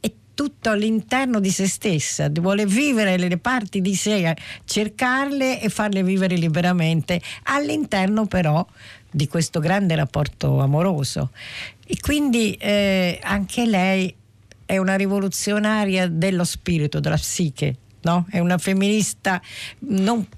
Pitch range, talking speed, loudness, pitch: 165-210 Hz, 120 wpm, -21 LUFS, 190 Hz